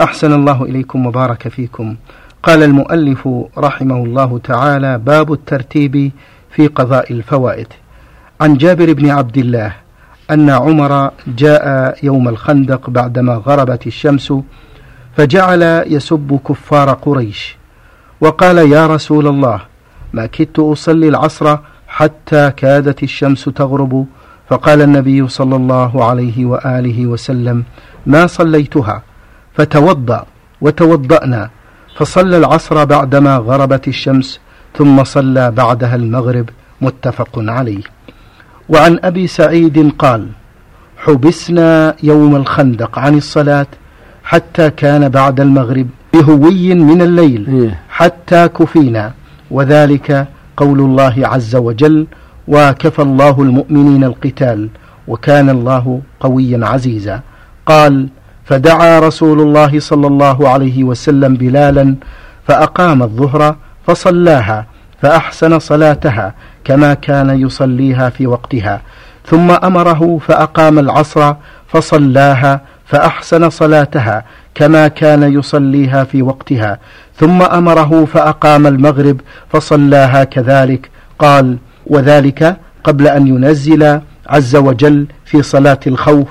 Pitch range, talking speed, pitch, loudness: 130-150 Hz, 100 wpm, 140 Hz, -9 LUFS